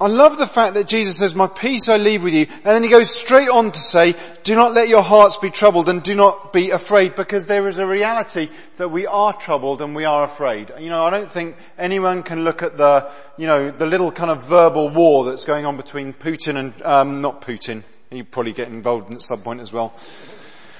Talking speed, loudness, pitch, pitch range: 235 wpm, -16 LUFS, 170 Hz, 145-205 Hz